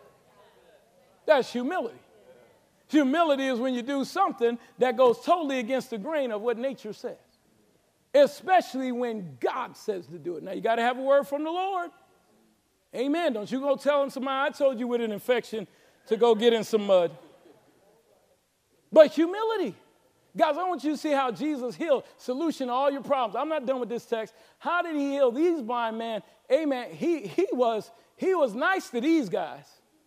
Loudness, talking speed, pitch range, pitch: -27 LUFS, 185 wpm, 235-310 Hz, 265 Hz